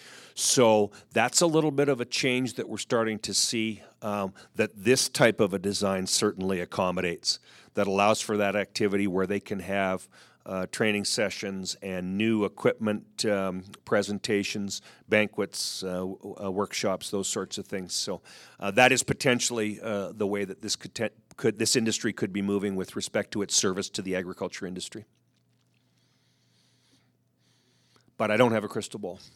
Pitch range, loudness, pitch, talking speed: 95-110 Hz, -27 LUFS, 100 Hz, 170 wpm